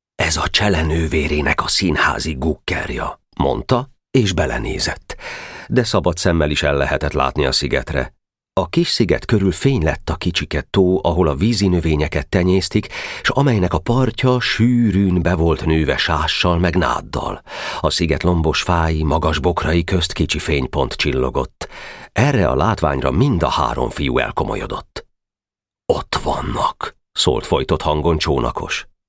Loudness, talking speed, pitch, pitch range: -18 LUFS, 140 wpm, 85 Hz, 80-100 Hz